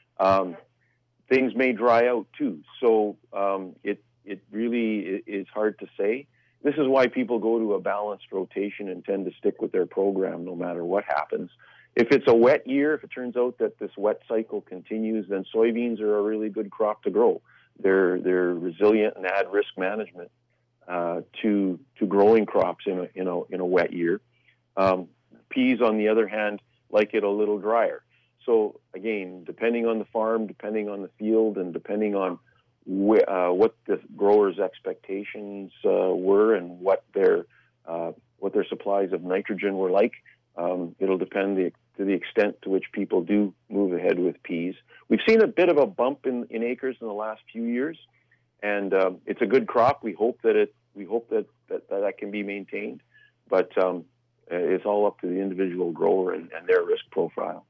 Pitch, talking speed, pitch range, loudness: 105 Hz, 190 wpm, 95-120 Hz, -25 LUFS